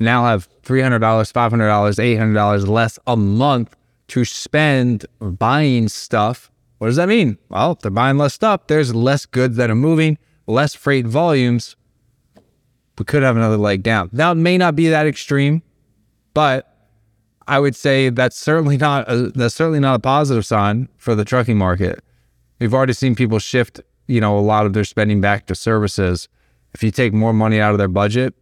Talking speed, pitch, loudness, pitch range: 190 wpm, 120 Hz, -16 LUFS, 105-140 Hz